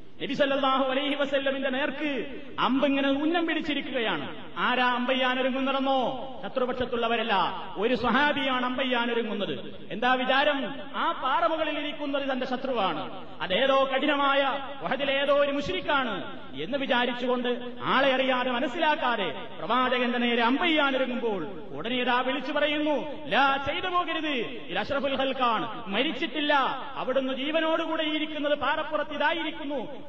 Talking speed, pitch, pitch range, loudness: 90 wpm, 270 Hz, 250-295 Hz, -27 LUFS